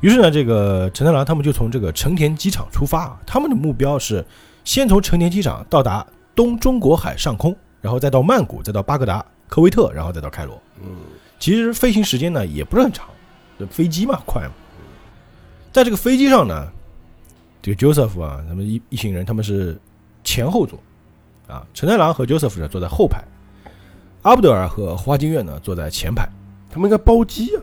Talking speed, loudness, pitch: 310 characters per minute, -17 LUFS, 120 Hz